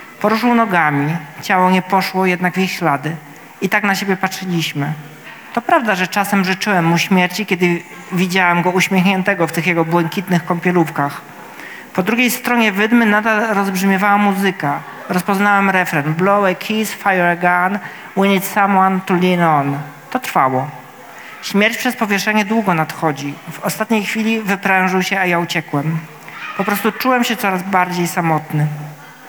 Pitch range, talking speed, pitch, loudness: 170-205 Hz, 150 wpm, 185 Hz, -16 LUFS